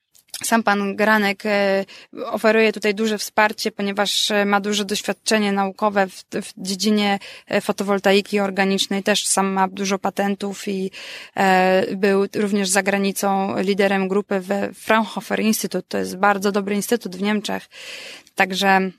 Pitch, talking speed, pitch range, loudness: 200 Hz, 130 wpm, 195-210 Hz, -20 LUFS